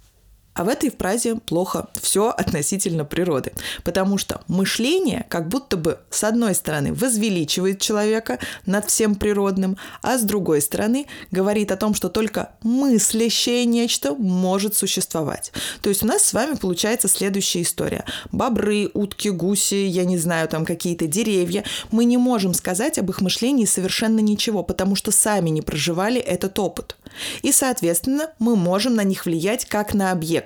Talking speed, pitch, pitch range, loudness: 155 wpm, 200 Hz, 185-225 Hz, -20 LUFS